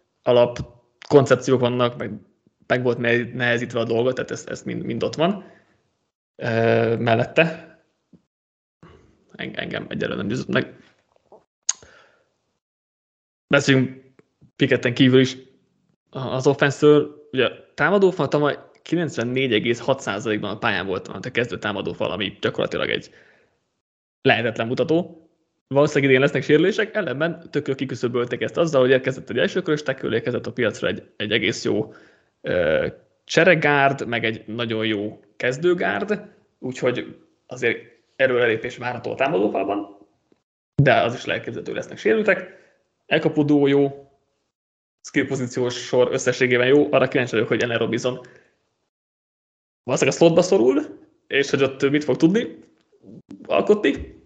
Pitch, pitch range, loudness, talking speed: 130 Hz, 120-155 Hz, -21 LUFS, 115 wpm